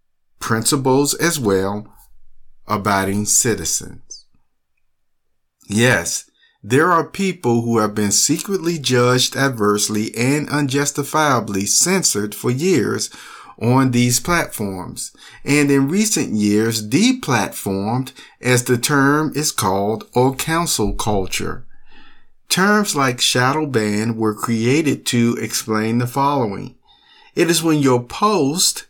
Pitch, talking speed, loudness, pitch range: 125 Hz, 105 wpm, -17 LUFS, 105-150 Hz